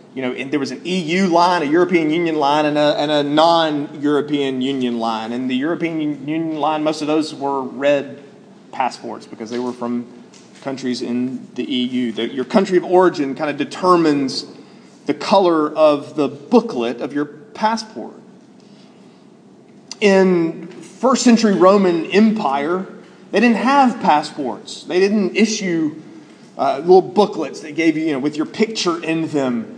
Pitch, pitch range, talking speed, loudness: 165 Hz, 145-210 Hz, 155 wpm, -17 LUFS